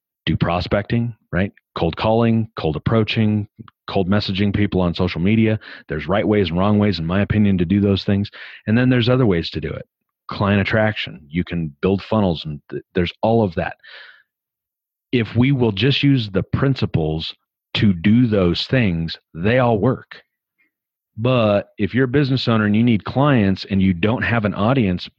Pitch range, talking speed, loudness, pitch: 95-115 Hz, 180 wpm, -19 LUFS, 105 Hz